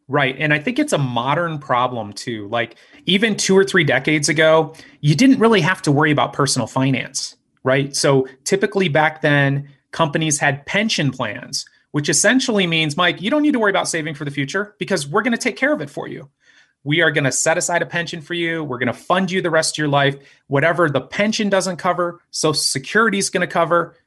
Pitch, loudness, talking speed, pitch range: 160 Hz, -18 LUFS, 220 wpm, 140-190 Hz